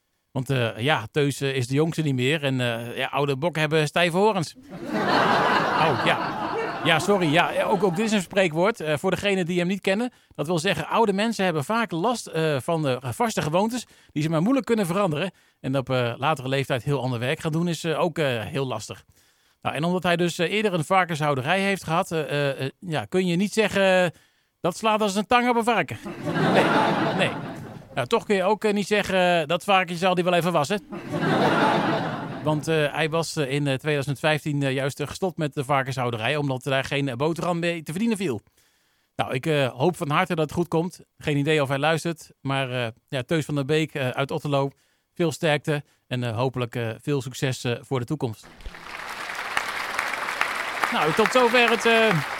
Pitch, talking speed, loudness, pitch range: 155 Hz, 195 wpm, -24 LUFS, 140-185 Hz